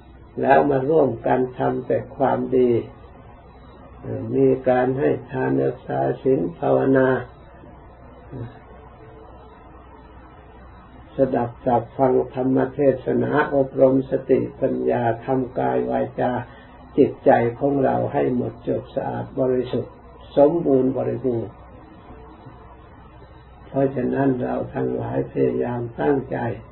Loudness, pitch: -21 LUFS, 120 Hz